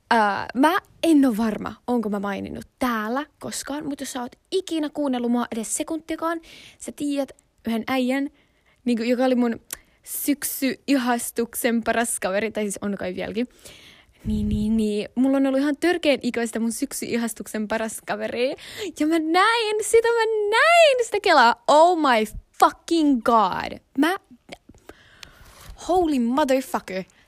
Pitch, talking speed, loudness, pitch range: 260 Hz, 145 wpm, -22 LUFS, 230-315 Hz